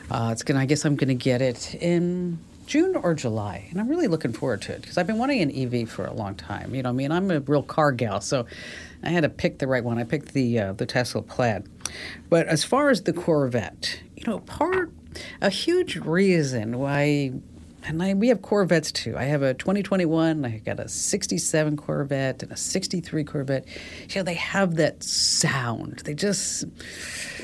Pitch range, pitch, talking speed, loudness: 120-175 Hz, 145 Hz, 210 wpm, -25 LUFS